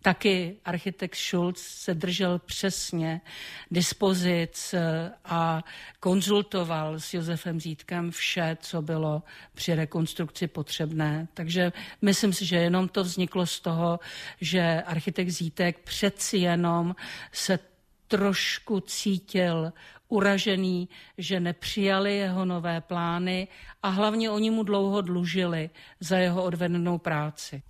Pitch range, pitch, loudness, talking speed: 170-195 Hz, 180 Hz, -28 LUFS, 110 wpm